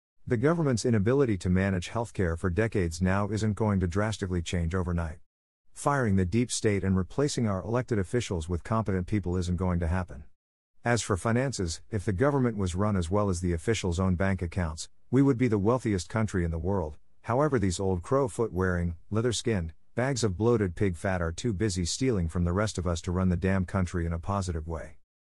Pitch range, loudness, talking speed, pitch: 90-115 Hz, -28 LUFS, 205 wpm, 95 Hz